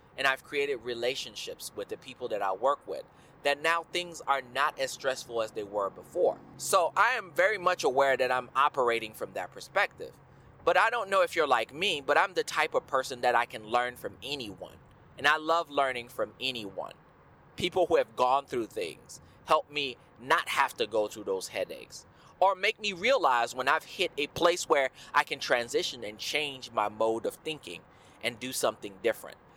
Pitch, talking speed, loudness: 150 Hz, 200 wpm, -29 LUFS